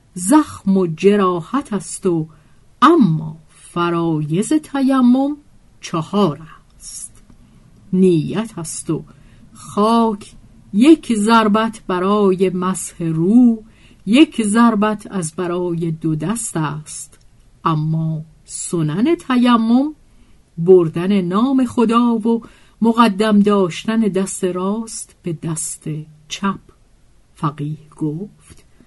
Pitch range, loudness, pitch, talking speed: 160-225 Hz, -17 LUFS, 190 Hz, 85 wpm